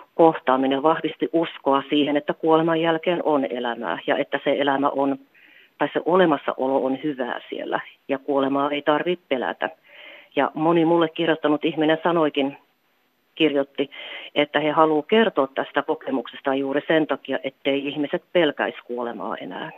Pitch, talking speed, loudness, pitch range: 145 Hz, 140 wpm, -22 LUFS, 135-160 Hz